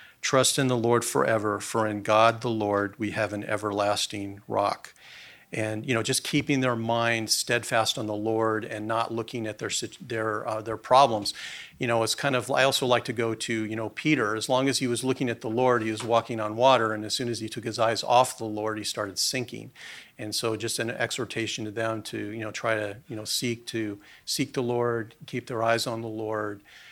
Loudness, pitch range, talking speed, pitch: -26 LUFS, 110-120 Hz, 225 wpm, 115 Hz